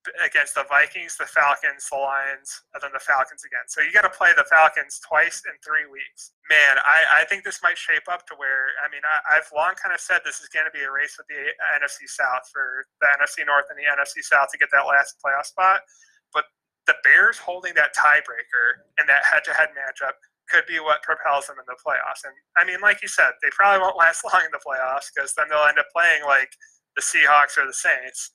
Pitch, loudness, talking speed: 175 Hz, -19 LUFS, 235 wpm